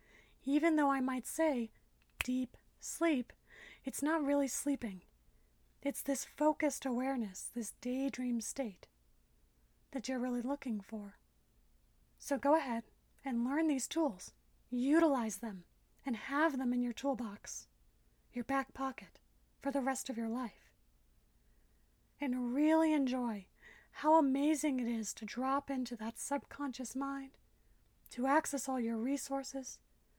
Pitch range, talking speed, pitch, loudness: 230-280 Hz, 130 wpm, 260 Hz, -36 LUFS